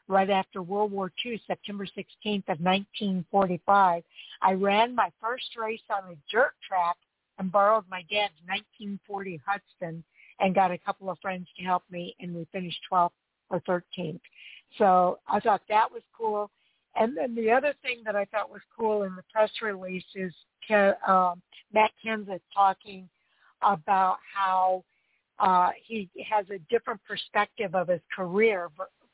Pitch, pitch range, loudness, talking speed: 195 Hz, 180-210 Hz, -28 LUFS, 150 wpm